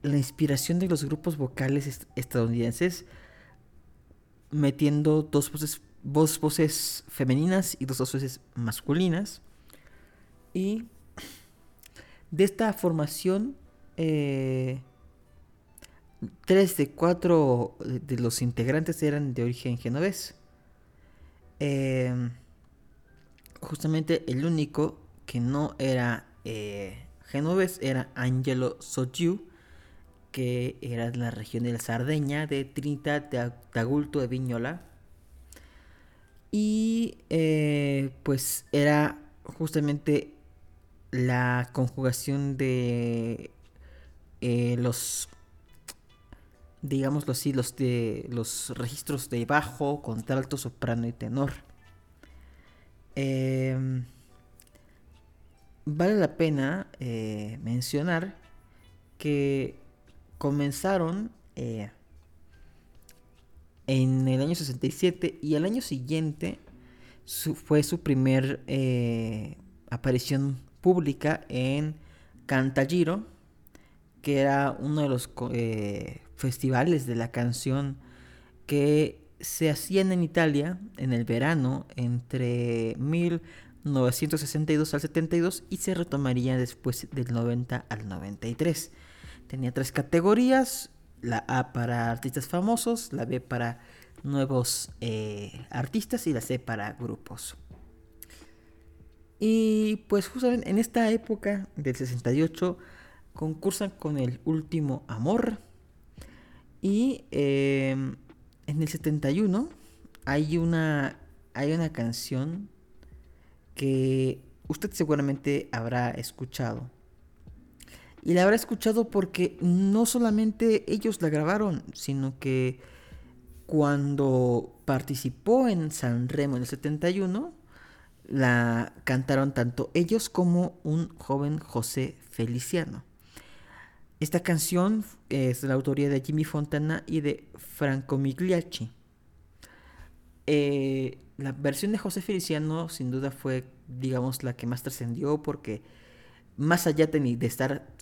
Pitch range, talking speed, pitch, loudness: 115-155 Hz, 100 wpm, 135 Hz, -28 LUFS